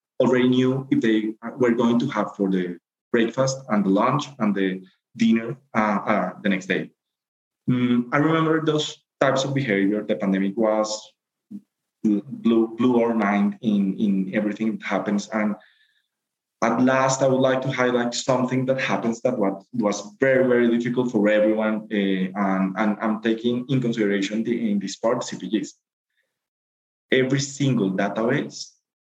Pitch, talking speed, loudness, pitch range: 110 Hz, 155 wpm, -22 LUFS, 100-125 Hz